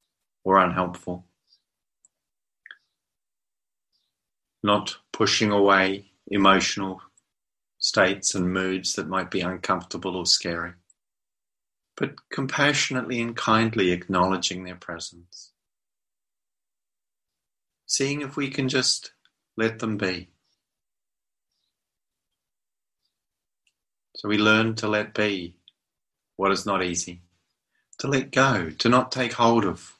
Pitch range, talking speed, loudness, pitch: 90-115 Hz, 95 wpm, -23 LUFS, 95 Hz